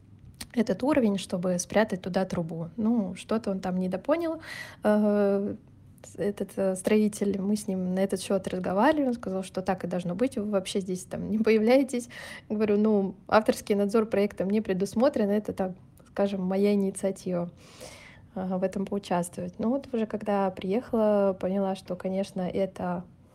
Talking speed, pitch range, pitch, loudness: 145 wpm, 190-215 Hz, 200 Hz, -28 LUFS